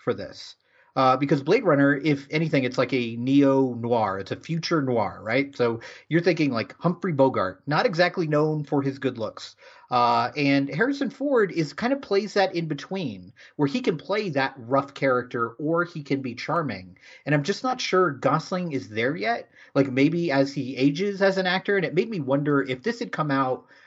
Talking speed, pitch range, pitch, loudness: 205 wpm, 130-180 Hz, 145 Hz, -24 LUFS